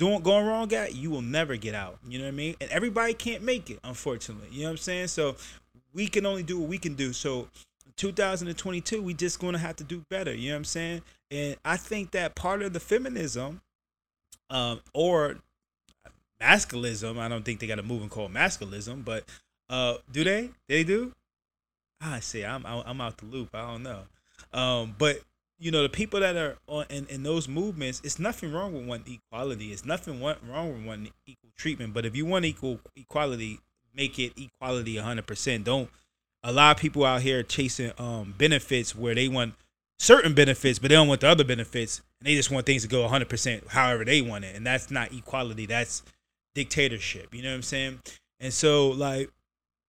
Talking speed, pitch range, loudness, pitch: 205 wpm, 120-160 Hz, -27 LUFS, 135 Hz